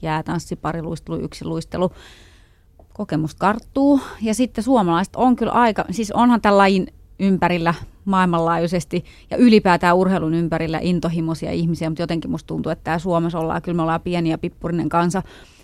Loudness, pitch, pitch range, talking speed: -20 LUFS, 170 Hz, 160-190 Hz, 155 wpm